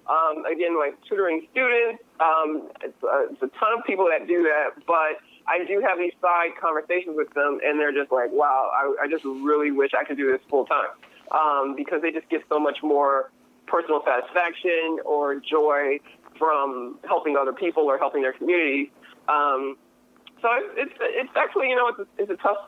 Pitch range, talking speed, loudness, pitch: 145-175 Hz, 195 wpm, -23 LUFS, 155 Hz